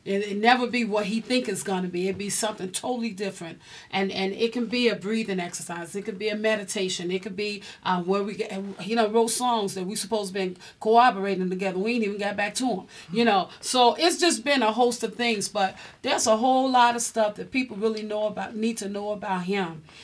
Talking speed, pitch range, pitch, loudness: 240 wpm, 195-230 Hz, 210 Hz, -25 LUFS